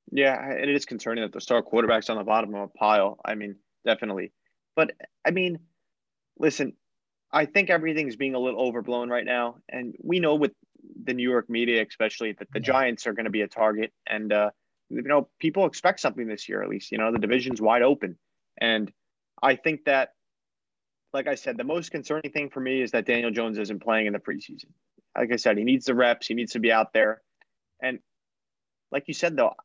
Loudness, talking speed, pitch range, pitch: -26 LUFS, 215 wpm, 110-150 Hz, 125 Hz